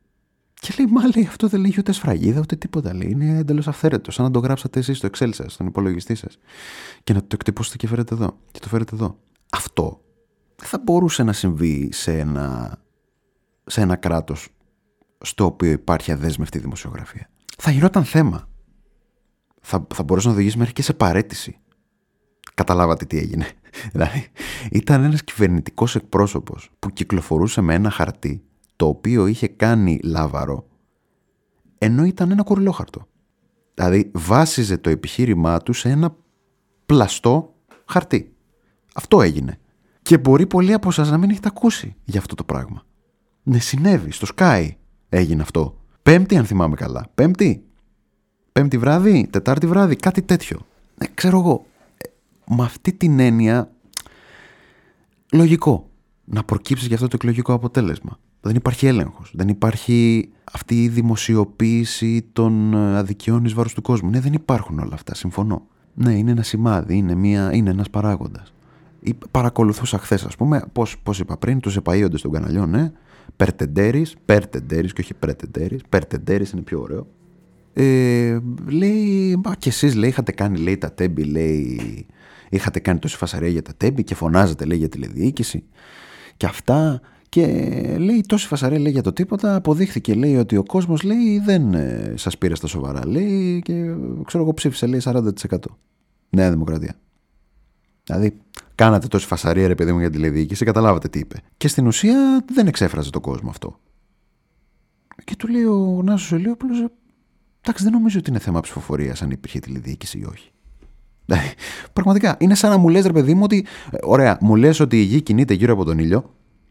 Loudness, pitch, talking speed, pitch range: -19 LUFS, 115 Hz, 160 wpm, 95-155 Hz